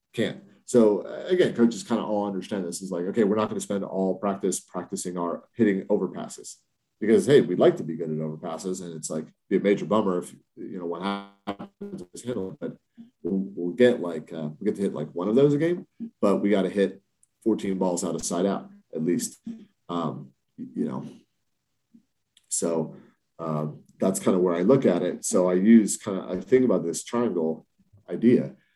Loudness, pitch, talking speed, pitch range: -25 LUFS, 95 Hz, 200 wpm, 85-115 Hz